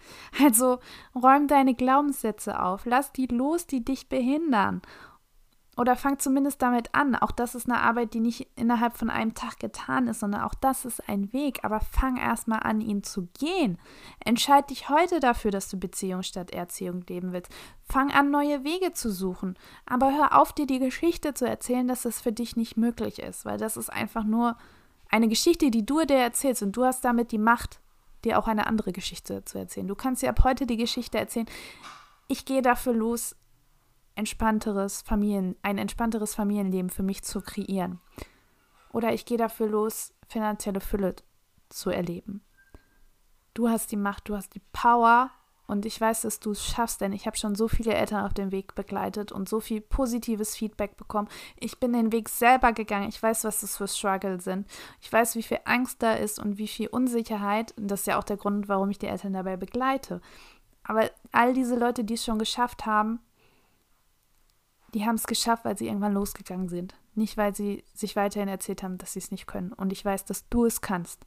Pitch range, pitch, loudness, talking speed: 200-245 Hz, 220 Hz, -27 LUFS, 200 wpm